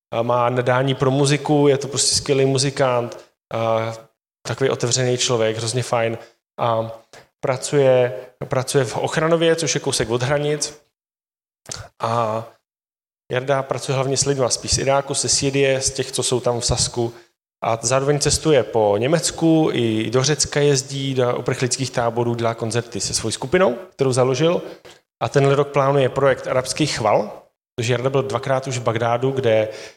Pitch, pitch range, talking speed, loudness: 130 Hz, 115-140 Hz, 155 wpm, -19 LUFS